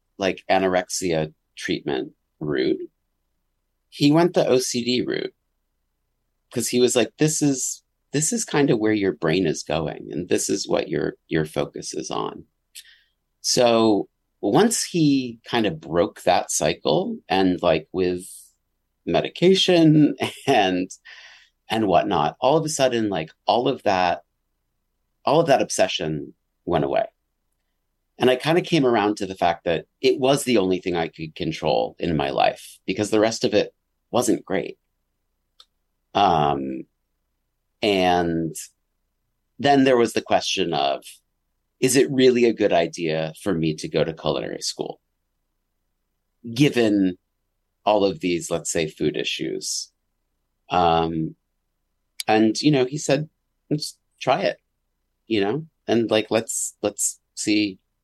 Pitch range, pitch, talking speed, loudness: 90-135 Hz, 110 Hz, 140 wpm, -22 LUFS